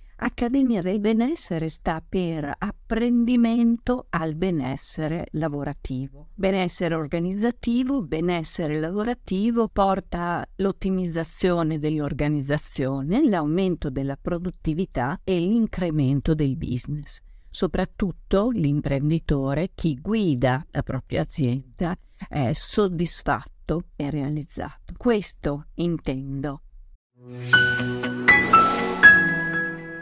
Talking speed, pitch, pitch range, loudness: 70 wpm, 165 Hz, 145-195 Hz, -23 LUFS